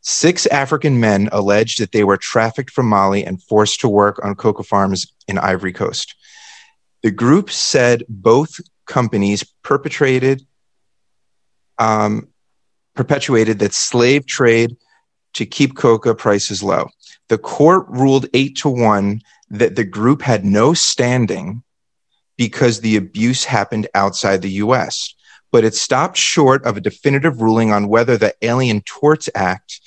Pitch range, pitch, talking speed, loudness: 105-130 Hz, 115 Hz, 140 wpm, -15 LUFS